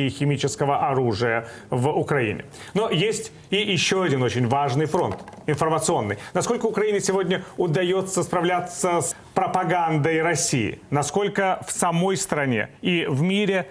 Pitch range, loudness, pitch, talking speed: 140-190 Hz, -23 LUFS, 170 Hz, 125 wpm